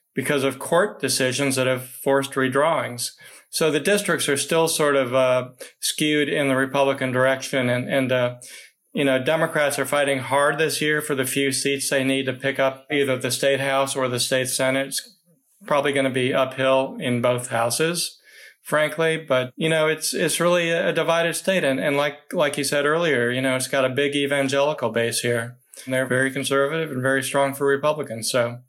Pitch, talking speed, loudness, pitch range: 135 Hz, 195 wpm, -21 LUFS, 130-150 Hz